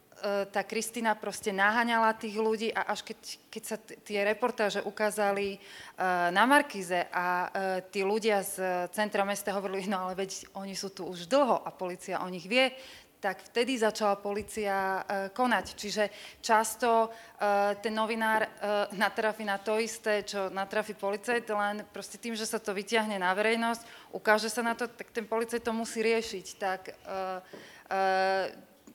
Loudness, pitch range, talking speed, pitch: -30 LUFS, 195-225 Hz, 165 wpm, 205 Hz